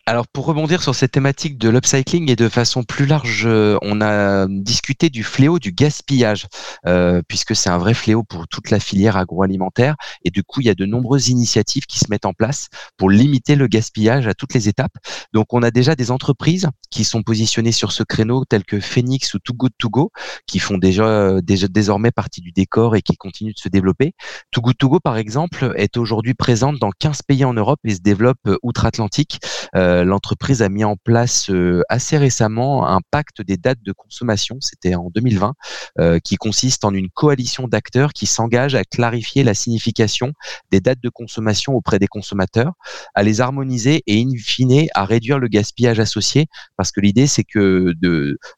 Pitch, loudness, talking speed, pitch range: 115 Hz, -17 LUFS, 195 wpm, 100-130 Hz